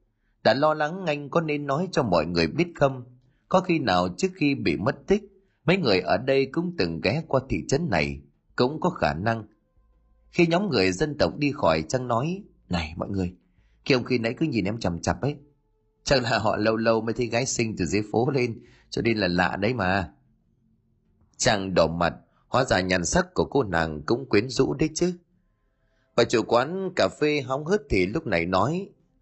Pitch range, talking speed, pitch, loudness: 105-150 Hz, 210 wpm, 125 Hz, -25 LUFS